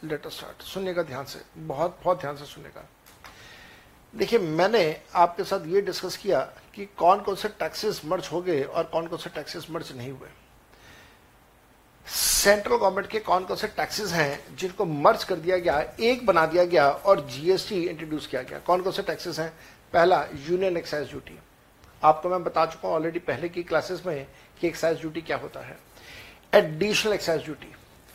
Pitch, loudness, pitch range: 170 Hz, -25 LUFS, 155-190 Hz